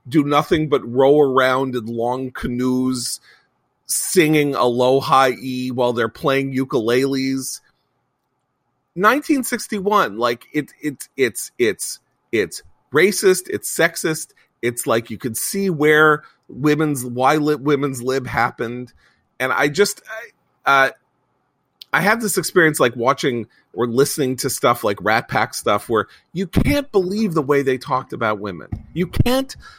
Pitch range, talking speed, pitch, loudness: 125-160 Hz, 135 wpm, 135 Hz, -19 LUFS